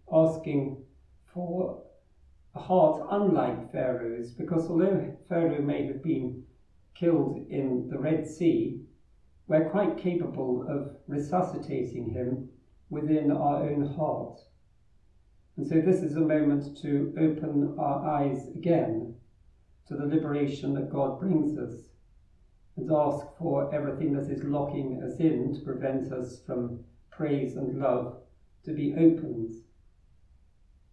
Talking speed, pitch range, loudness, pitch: 125 wpm, 125-155 Hz, -29 LUFS, 145 Hz